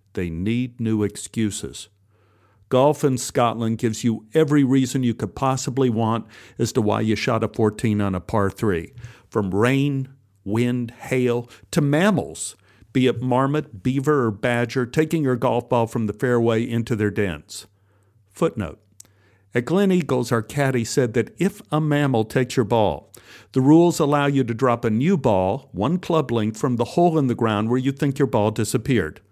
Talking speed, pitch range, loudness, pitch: 175 wpm, 105-135 Hz, -21 LUFS, 120 Hz